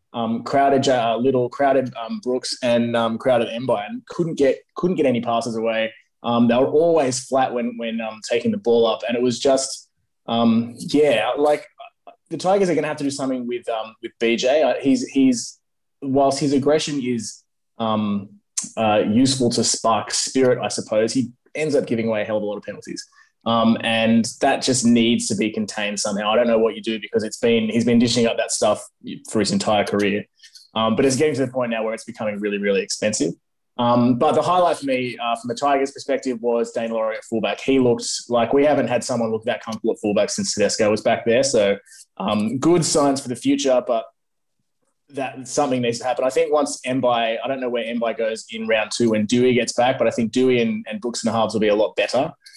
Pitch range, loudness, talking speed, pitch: 115-135 Hz, -20 LUFS, 225 wpm, 120 Hz